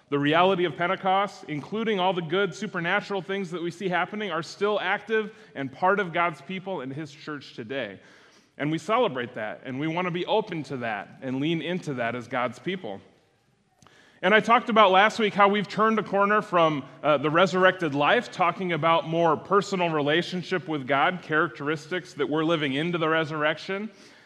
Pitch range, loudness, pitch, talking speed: 150-195 Hz, -25 LUFS, 175 Hz, 185 wpm